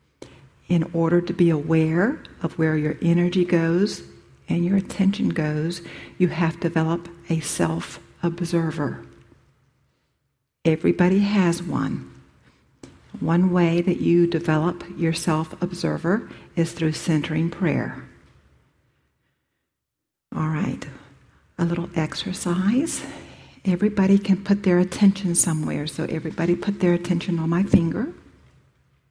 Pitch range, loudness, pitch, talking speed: 155-180 Hz, -22 LUFS, 170 Hz, 115 wpm